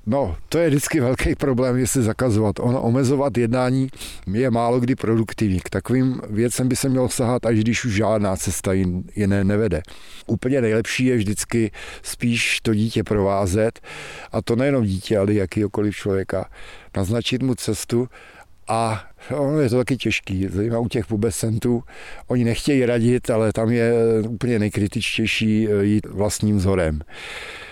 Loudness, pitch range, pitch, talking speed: -21 LUFS, 105-125 Hz, 115 Hz, 145 wpm